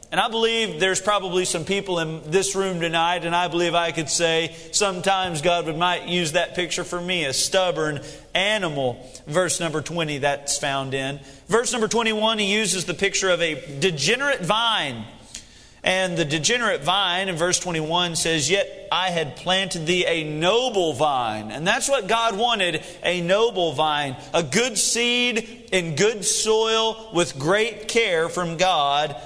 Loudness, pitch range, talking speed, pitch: -21 LUFS, 165-200 Hz, 165 wpm, 175 Hz